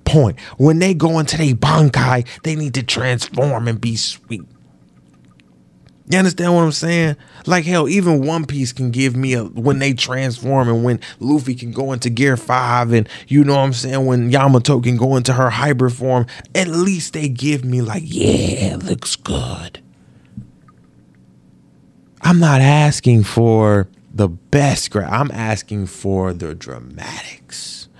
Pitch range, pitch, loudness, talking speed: 115-145 Hz, 130 Hz, -16 LUFS, 160 wpm